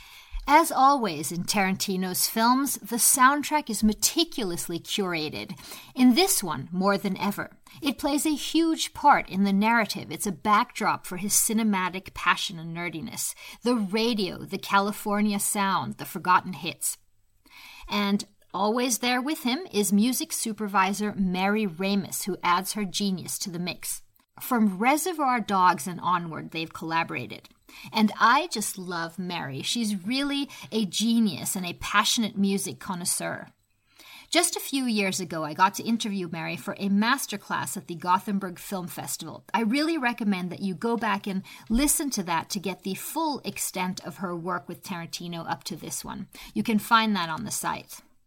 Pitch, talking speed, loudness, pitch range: 200 Hz, 160 wpm, -26 LUFS, 180-230 Hz